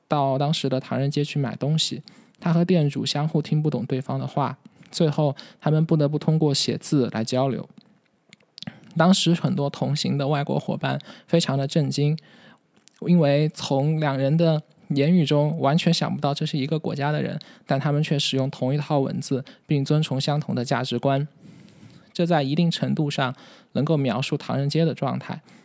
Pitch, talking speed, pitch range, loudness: 150 Hz, 265 characters per minute, 140-165 Hz, -23 LUFS